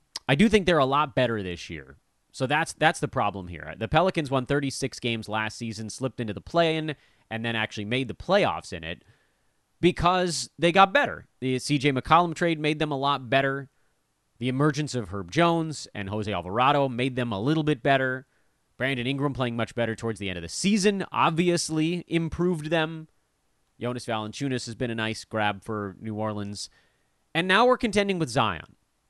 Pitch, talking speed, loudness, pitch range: 130 Hz, 190 wpm, -26 LUFS, 110-160 Hz